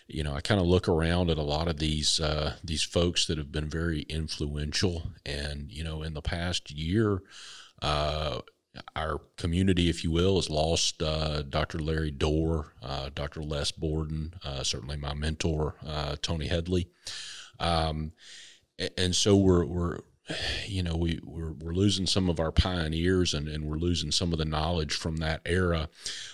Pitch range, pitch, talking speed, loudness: 75-85 Hz, 80 Hz, 175 wpm, -29 LUFS